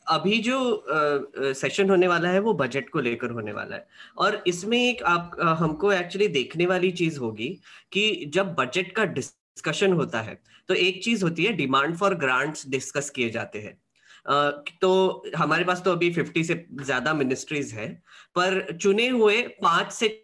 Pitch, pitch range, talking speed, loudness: 175 Hz, 145-195 Hz, 180 wpm, -24 LUFS